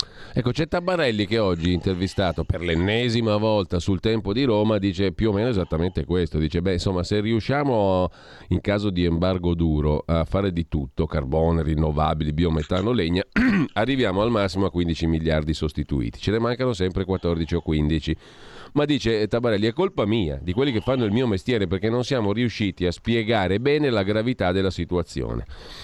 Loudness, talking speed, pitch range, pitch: -23 LUFS, 175 wpm, 85-115 Hz, 95 Hz